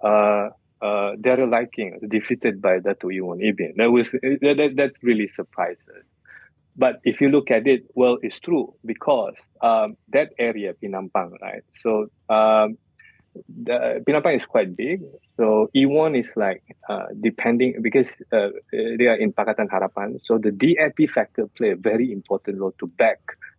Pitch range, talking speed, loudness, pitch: 105-135 Hz, 150 wpm, -21 LUFS, 115 Hz